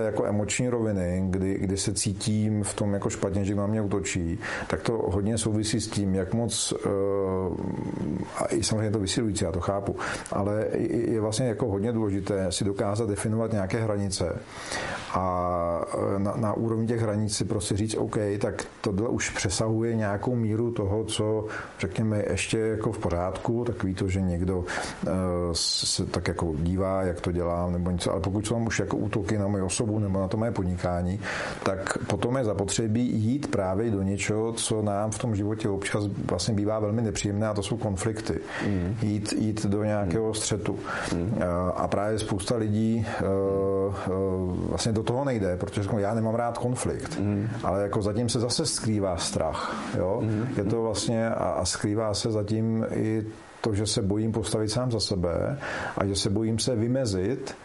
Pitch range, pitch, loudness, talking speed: 95-115 Hz, 105 Hz, -27 LUFS, 170 wpm